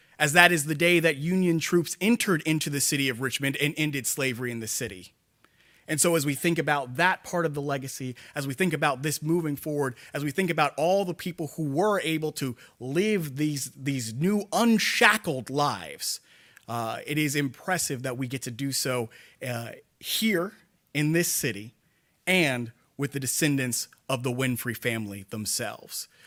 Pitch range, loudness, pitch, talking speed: 130-170 Hz, -26 LUFS, 145 Hz, 180 wpm